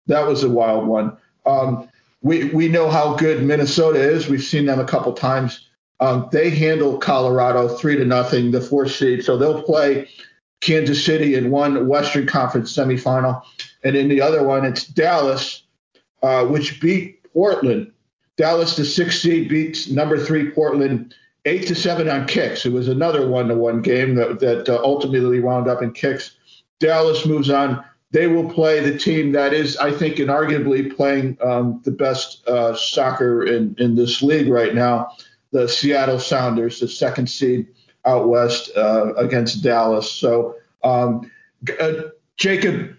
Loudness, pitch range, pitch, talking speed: -18 LUFS, 125-155 Hz, 135 Hz, 165 wpm